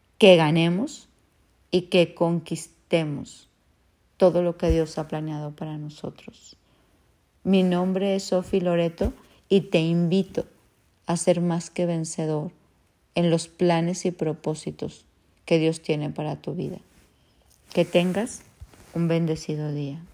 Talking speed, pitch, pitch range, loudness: 125 wpm, 170 Hz, 155-180 Hz, -24 LUFS